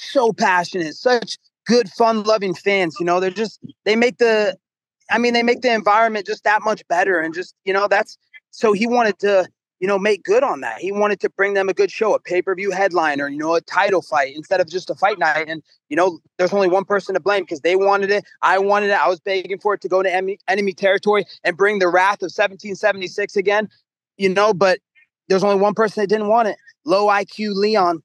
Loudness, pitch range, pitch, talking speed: -18 LUFS, 185-210 Hz, 200 Hz, 235 wpm